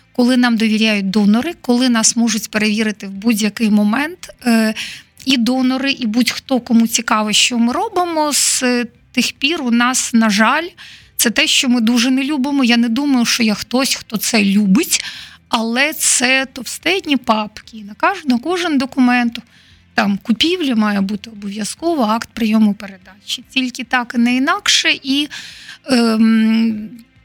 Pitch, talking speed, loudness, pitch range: 240 Hz, 145 wpm, -15 LUFS, 220-265 Hz